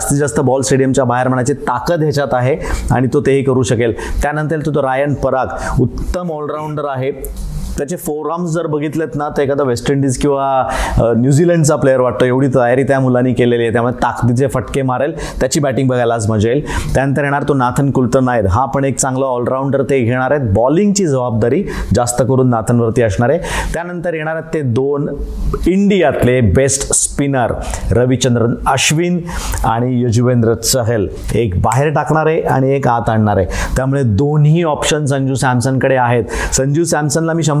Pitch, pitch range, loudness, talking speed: 135 Hz, 125-145 Hz, -14 LUFS, 170 wpm